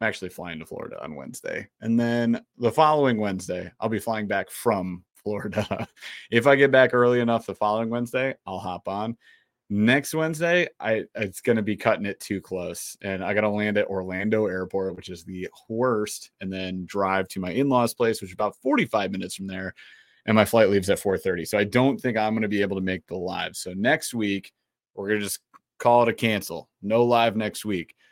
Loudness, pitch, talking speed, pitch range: -24 LUFS, 105 Hz, 205 wpm, 95-120 Hz